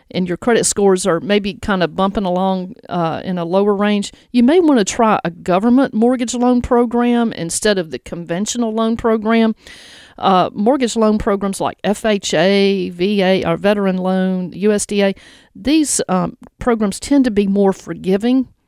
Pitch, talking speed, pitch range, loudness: 205 Hz, 160 wpm, 185-235 Hz, -16 LUFS